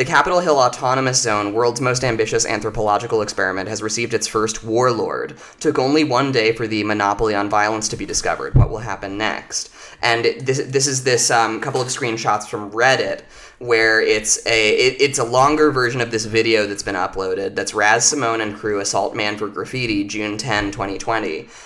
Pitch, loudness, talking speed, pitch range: 115 Hz, -18 LUFS, 190 wpm, 105-130 Hz